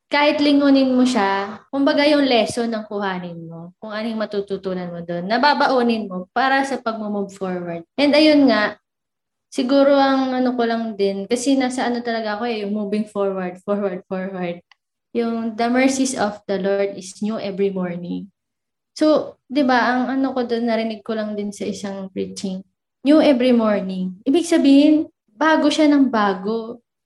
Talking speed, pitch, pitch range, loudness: 160 wpm, 225 Hz, 195-265 Hz, -19 LUFS